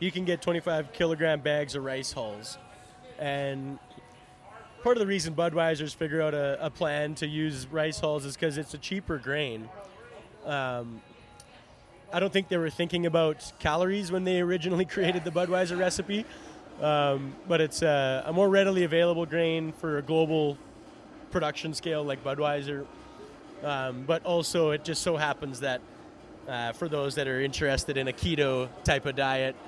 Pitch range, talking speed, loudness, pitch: 140-175 Hz, 165 wpm, -29 LUFS, 155 Hz